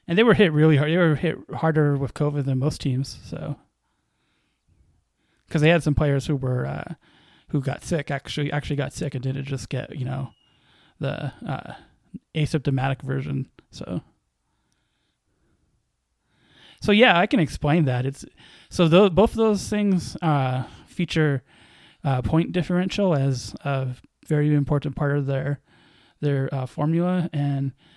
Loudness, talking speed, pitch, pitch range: -23 LUFS, 150 wpm, 145 Hz, 135-160 Hz